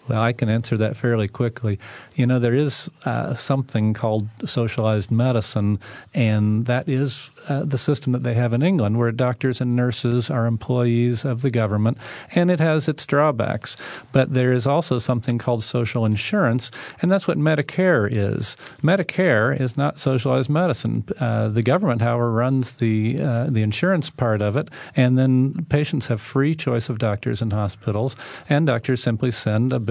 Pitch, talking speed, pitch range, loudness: 125 Hz, 175 wpm, 115-140 Hz, -21 LUFS